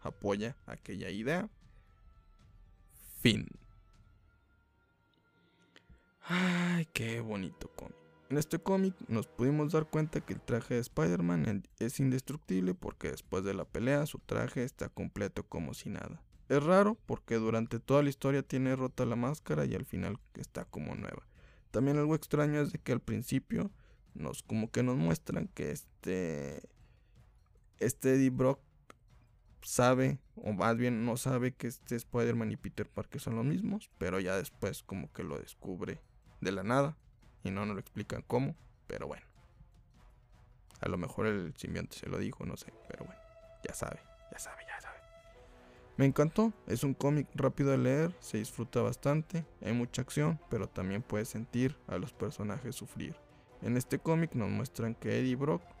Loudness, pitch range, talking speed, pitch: -35 LUFS, 110-145 Hz, 160 wpm, 125 Hz